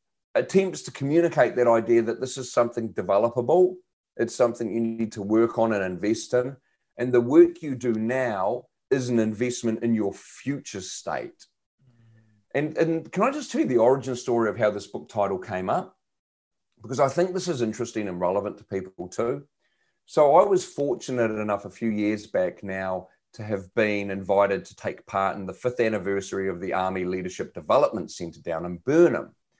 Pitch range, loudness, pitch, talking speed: 100-130 Hz, -25 LUFS, 115 Hz, 185 wpm